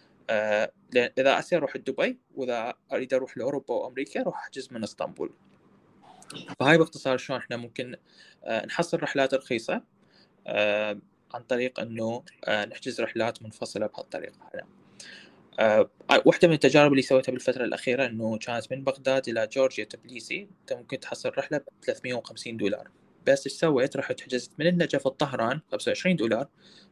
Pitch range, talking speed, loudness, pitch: 120-145 Hz, 140 wpm, -27 LUFS, 130 Hz